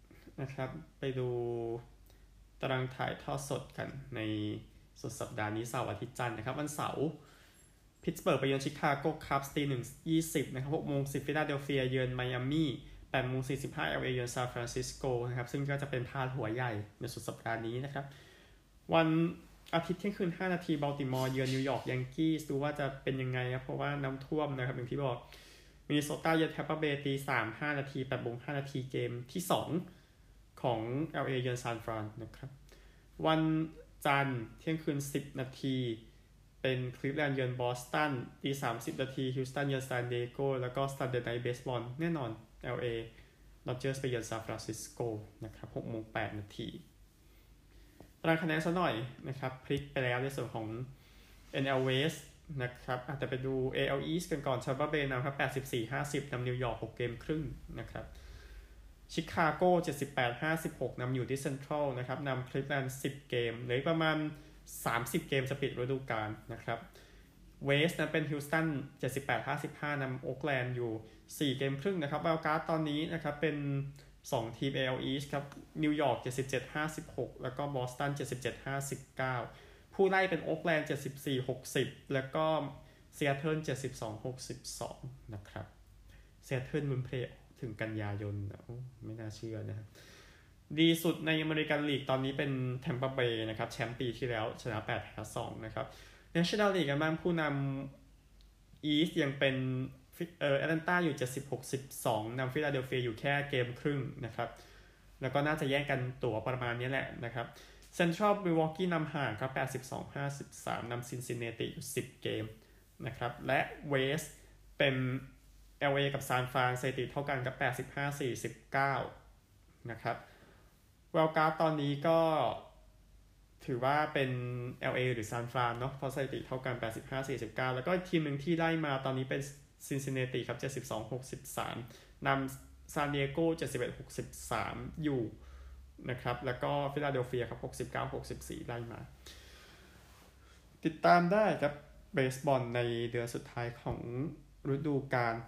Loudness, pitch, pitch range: -36 LUFS, 130 Hz, 120-145 Hz